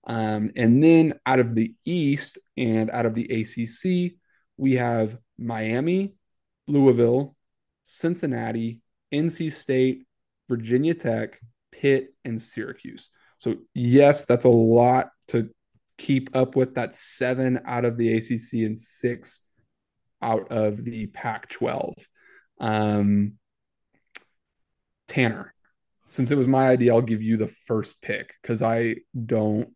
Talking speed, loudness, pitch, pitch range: 125 wpm, -23 LUFS, 120 Hz, 115-135 Hz